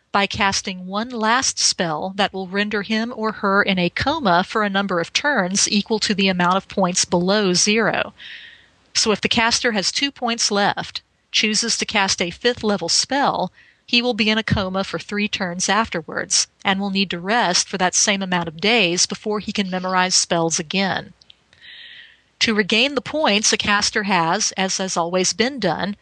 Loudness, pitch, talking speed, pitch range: -19 LUFS, 205 Hz, 185 wpm, 185-225 Hz